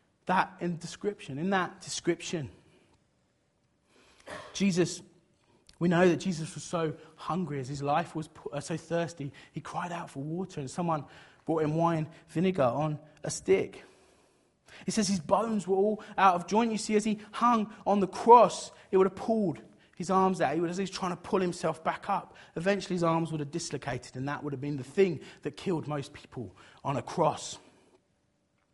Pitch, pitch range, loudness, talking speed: 170 Hz, 150-195 Hz, -30 LUFS, 190 wpm